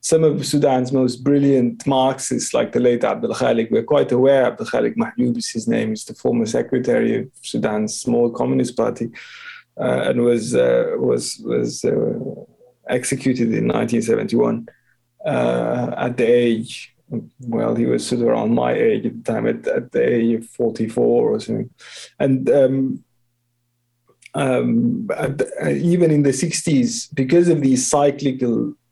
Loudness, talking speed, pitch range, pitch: -19 LUFS, 155 wpm, 120-165 Hz, 130 Hz